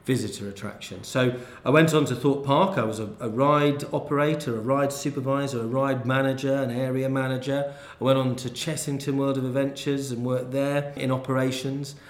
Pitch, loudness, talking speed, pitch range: 135 Hz, -25 LUFS, 185 wpm, 125-140 Hz